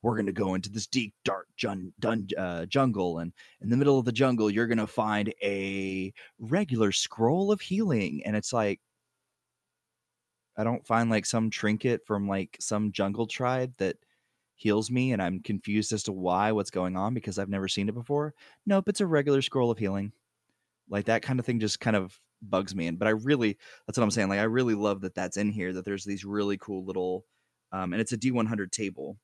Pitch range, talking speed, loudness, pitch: 100-120 Hz, 215 wpm, -29 LUFS, 110 Hz